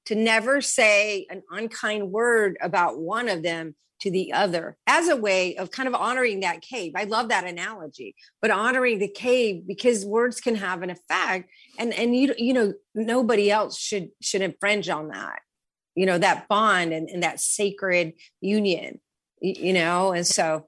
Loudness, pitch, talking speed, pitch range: -23 LUFS, 205 Hz, 175 wpm, 185-230 Hz